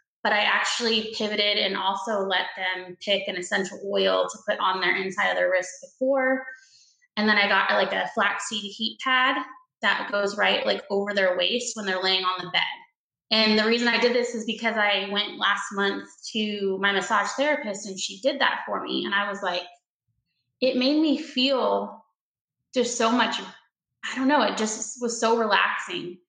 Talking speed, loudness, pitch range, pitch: 190 wpm, -24 LUFS, 190-240 Hz, 205 Hz